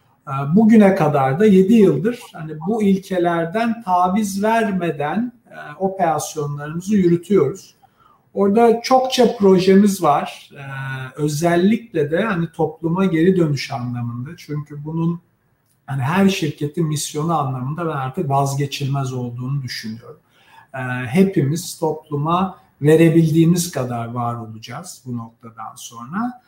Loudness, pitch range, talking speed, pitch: -18 LUFS, 135-190 Hz, 100 wpm, 160 Hz